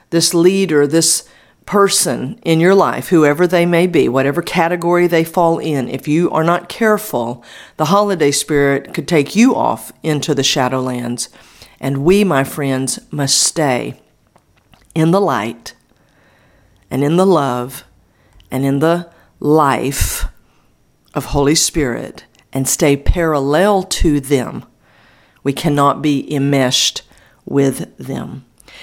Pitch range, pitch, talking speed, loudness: 135-170 Hz, 145 Hz, 130 wpm, -15 LUFS